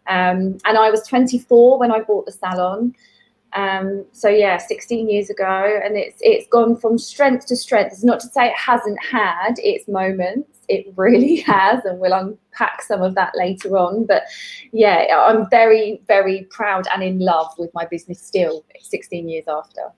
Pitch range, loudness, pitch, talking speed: 190-245 Hz, -17 LUFS, 210 Hz, 180 wpm